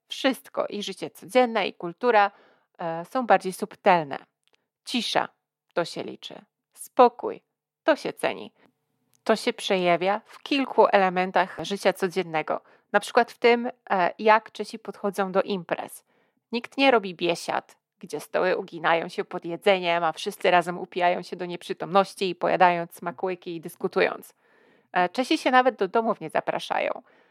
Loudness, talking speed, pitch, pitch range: -25 LUFS, 145 wpm, 195 Hz, 175-220 Hz